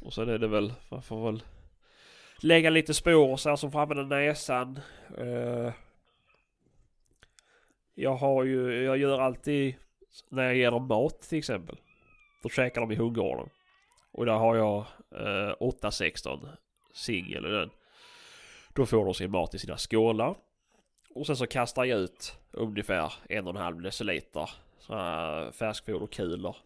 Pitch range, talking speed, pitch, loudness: 110-140 Hz, 140 wpm, 125 Hz, -29 LUFS